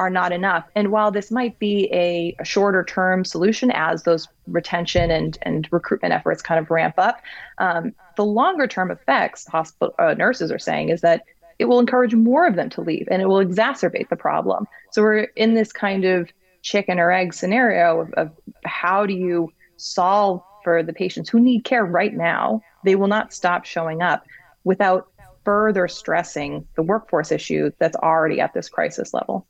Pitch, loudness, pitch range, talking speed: 185 Hz, -20 LUFS, 170-215 Hz, 185 wpm